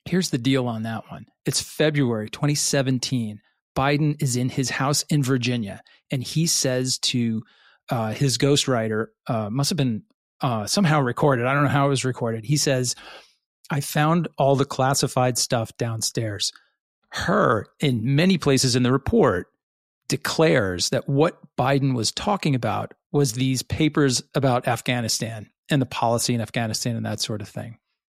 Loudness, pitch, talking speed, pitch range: -22 LUFS, 130 Hz, 160 wpm, 115-145 Hz